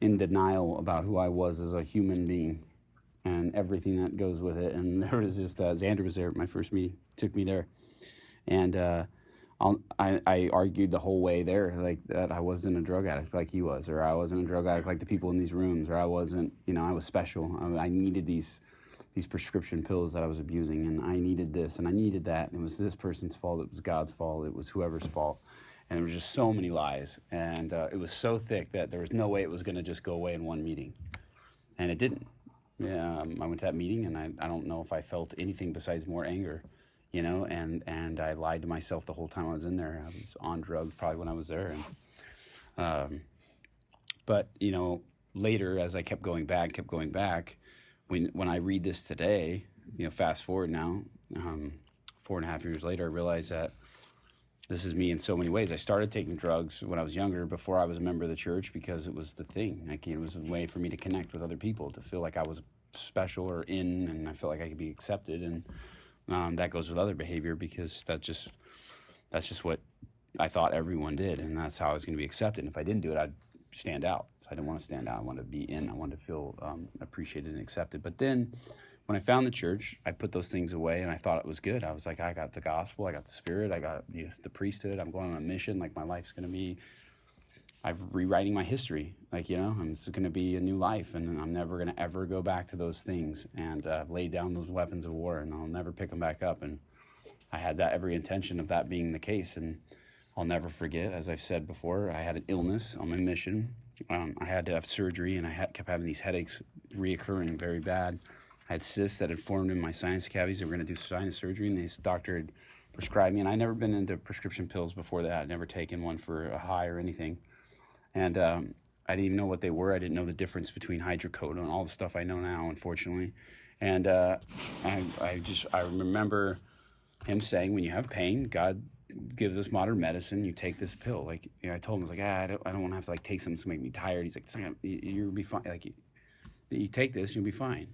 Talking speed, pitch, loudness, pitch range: 250 wpm, 90 Hz, -34 LUFS, 80-95 Hz